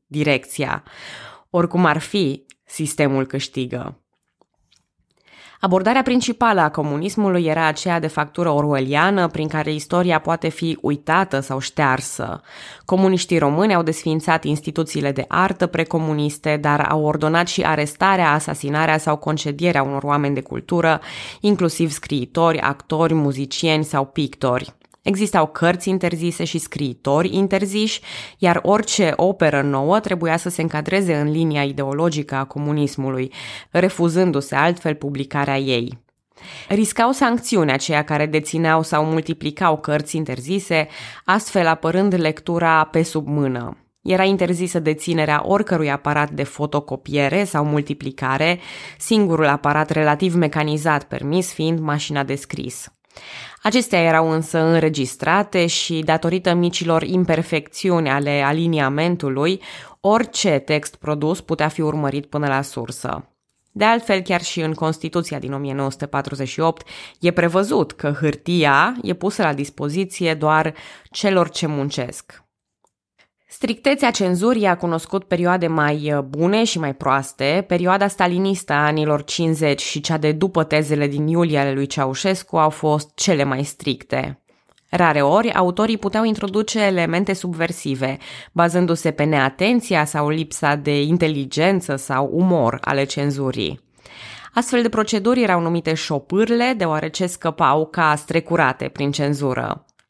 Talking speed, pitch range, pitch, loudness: 120 wpm, 145-180 Hz, 160 Hz, -19 LUFS